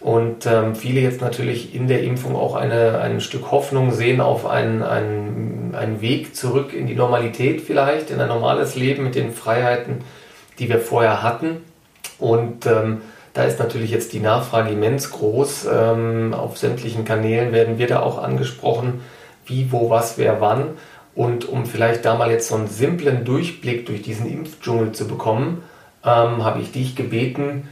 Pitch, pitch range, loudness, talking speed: 120 Hz, 115-130 Hz, -20 LUFS, 170 wpm